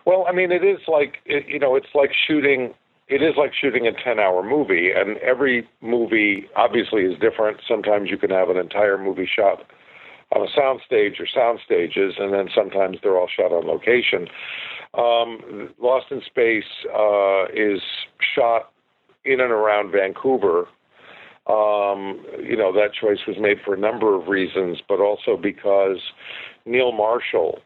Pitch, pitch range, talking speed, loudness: 115 Hz, 100-150 Hz, 165 wpm, -20 LUFS